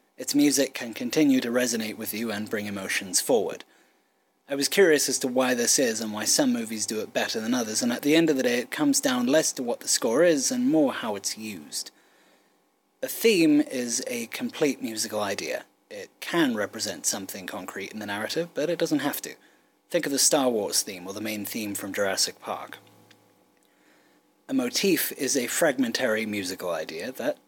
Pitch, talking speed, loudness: 140 Hz, 200 wpm, -25 LUFS